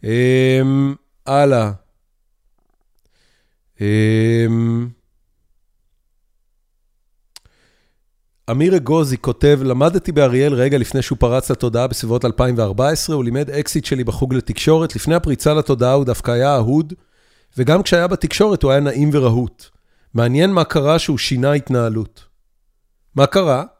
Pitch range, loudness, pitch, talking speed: 120-150 Hz, -16 LUFS, 135 Hz, 110 wpm